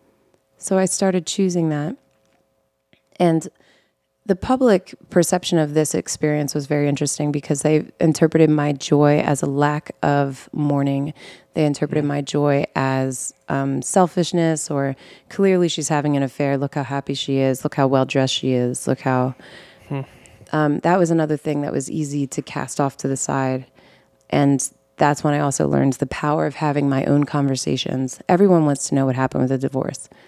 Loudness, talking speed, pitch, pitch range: -20 LUFS, 170 wpm, 145 Hz, 135-155 Hz